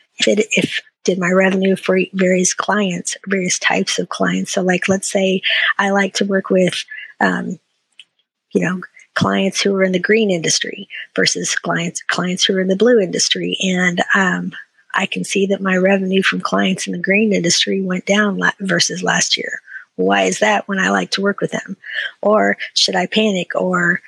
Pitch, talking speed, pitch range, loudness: 190 Hz, 190 wpm, 185-200 Hz, -16 LUFS